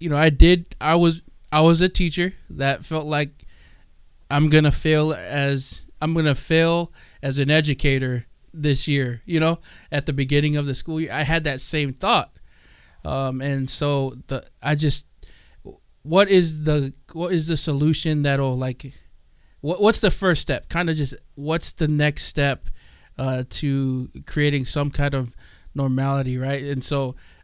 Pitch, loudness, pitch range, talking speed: 145 Hz, -21 LUFS, 135-160 Hz, 165 wpm